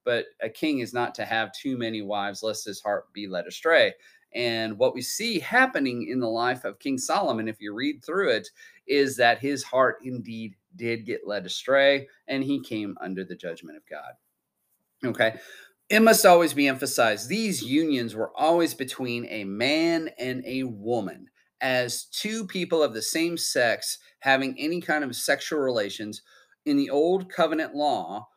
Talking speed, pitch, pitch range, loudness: 175 wpm, 135 Hz, 110-185 Hz, -25 LUFS